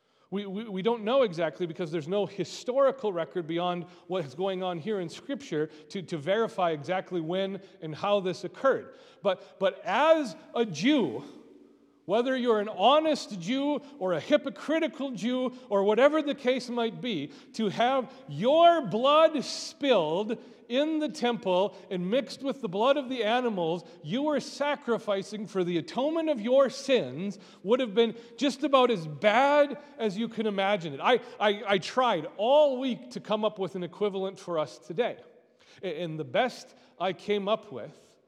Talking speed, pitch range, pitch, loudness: 170 wpm, 190-265 Hz, 220 Hz, -28 LUFS